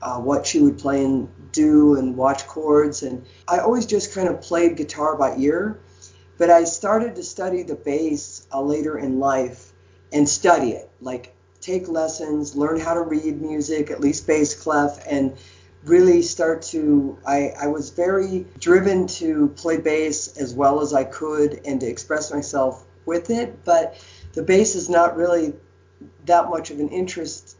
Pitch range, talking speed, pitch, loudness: 135-170 Hz, 175 wpm, 150 Hz, -20 LUFS